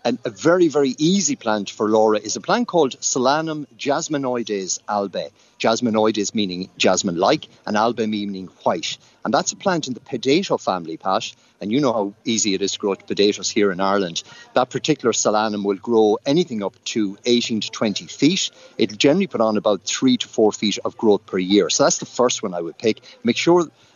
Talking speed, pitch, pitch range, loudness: 200 wpm, 110 Hz, 100-130 Hz, -20 LUFS